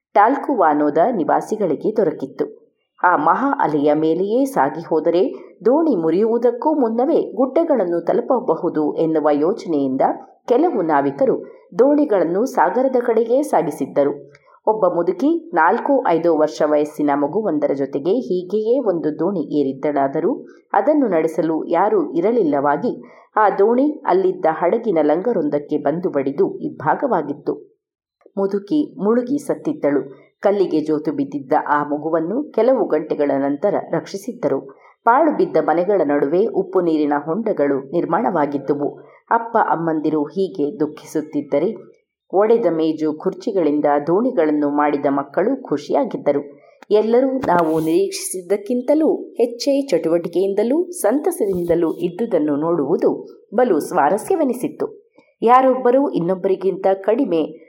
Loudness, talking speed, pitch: -18 LUFS, 95 wpm, 190 Hz